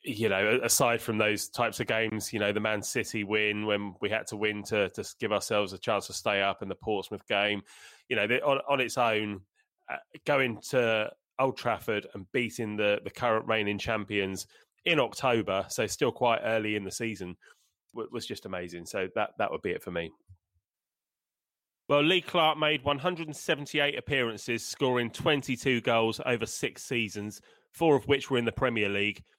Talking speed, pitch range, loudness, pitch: 190 wpm, 105-135 Hz, -29 LUFS, 110 Hz